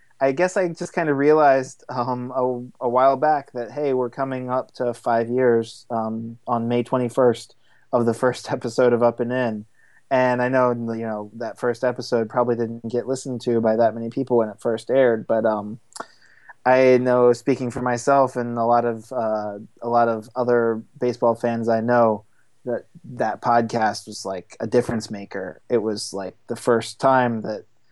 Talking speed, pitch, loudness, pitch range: 190 wpm, 120 Hz, -22 LUFS, 115-125 Hz